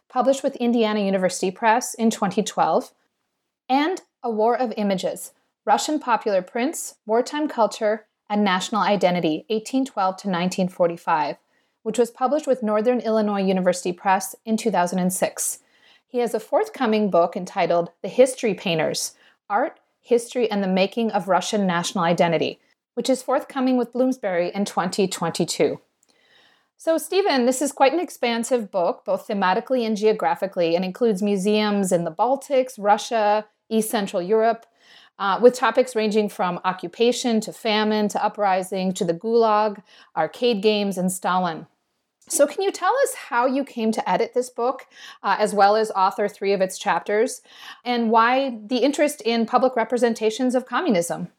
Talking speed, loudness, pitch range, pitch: 150 wpm, -22 LUFS, 195-250 Hz, 220 Hz